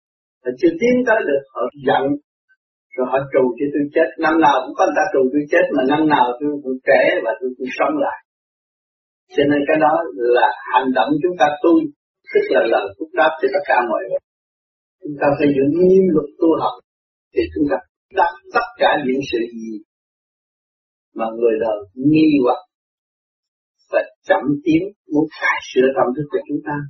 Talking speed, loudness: 190 wpm, -17 LUFS